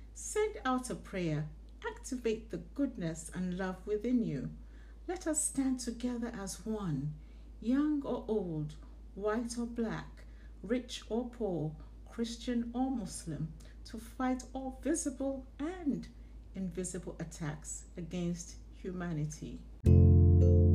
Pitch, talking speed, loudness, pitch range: 215 Hz, 110 wpm, -35 LUFS, 170-255 Hz